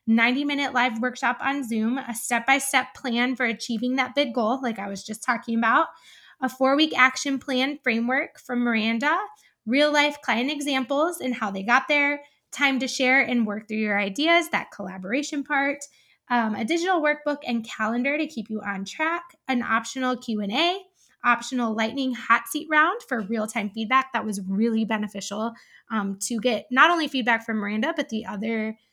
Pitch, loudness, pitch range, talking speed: 250 Hz, -24 LUFS, 225-280 Hz, 185 wpm